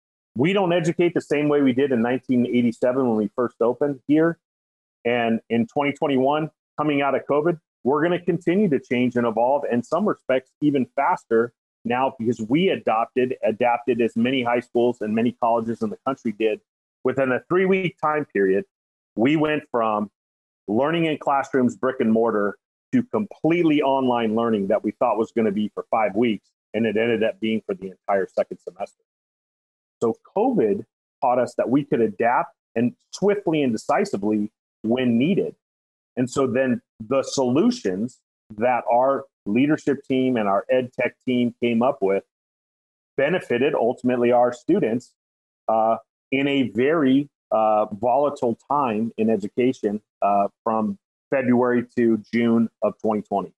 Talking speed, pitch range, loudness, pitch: 160 wpm, 110-140 Hz, -22 LUFS, 125 Hz